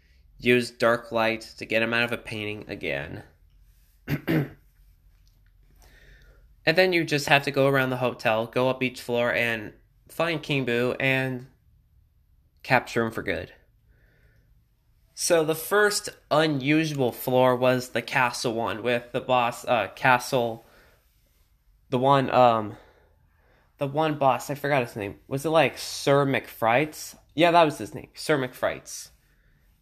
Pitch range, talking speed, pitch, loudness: 110-135 Hz, 140 wpm, 125 Hz, -24 LUFS